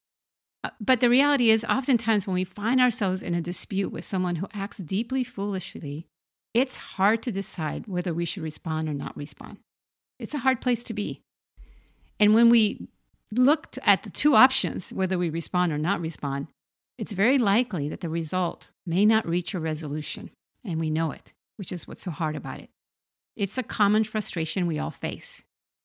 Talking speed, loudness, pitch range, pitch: 180 wpm, -25 LUFS, 165-225 Hz, 190 Hz